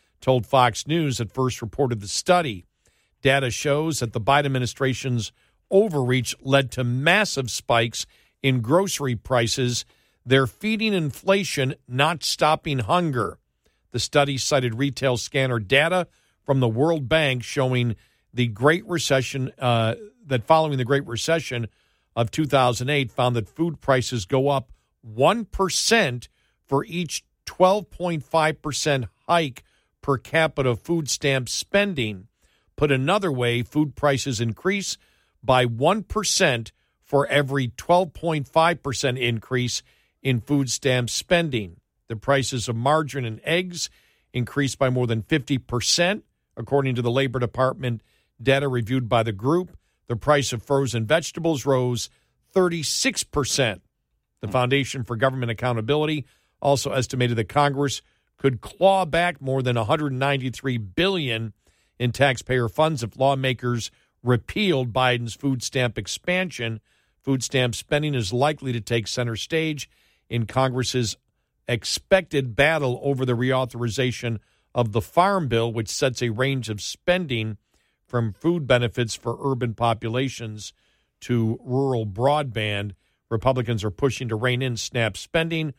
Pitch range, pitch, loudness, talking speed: 120-145 Hz, 130 Hz, -23 LUFS, 125 wpm